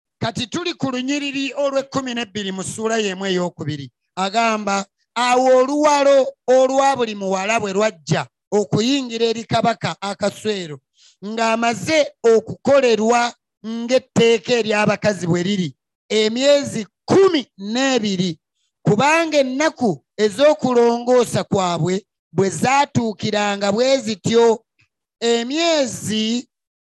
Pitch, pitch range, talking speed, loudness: 230 Hz, 200-260 Hz, 85 wpm, -18 LUFS